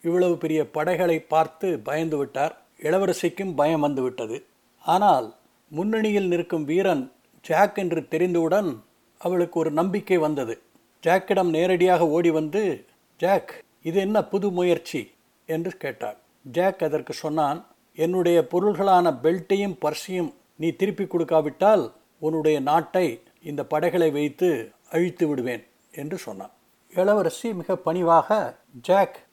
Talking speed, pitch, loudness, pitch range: 110 wpm, 170 Hz, -23 LUFS, 160-190 Hz